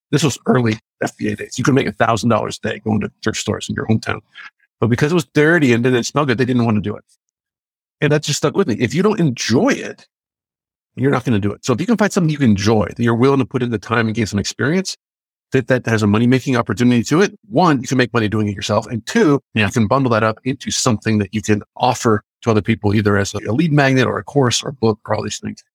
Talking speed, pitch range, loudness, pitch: 280 wpm, 110-140 Hz, -17 LUFS, 120 Hz